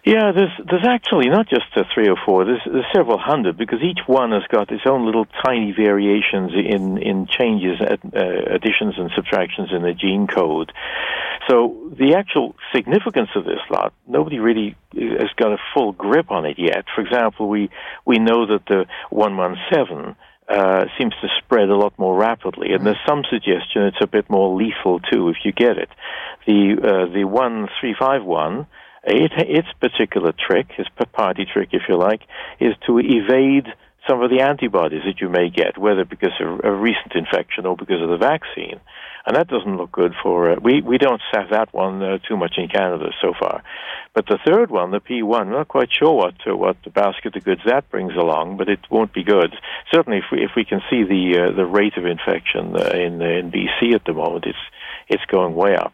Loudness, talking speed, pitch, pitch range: -18 LUFS, 210 wpm, 105 Hz, 95-120 Hz